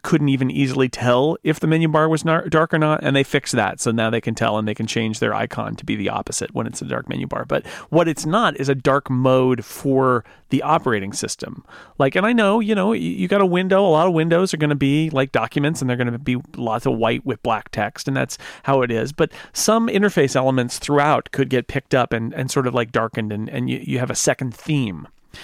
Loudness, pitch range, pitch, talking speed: -20 LUFS, 120-160 Hz, 135 Hz, 255 wpm